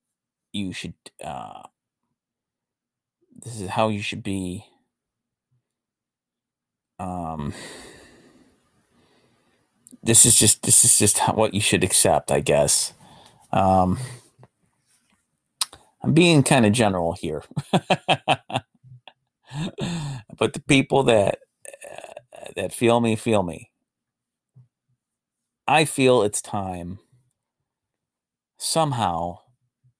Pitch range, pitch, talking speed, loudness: 100-130 Hz, 115 Hz, 90 wpm, -19 LUFS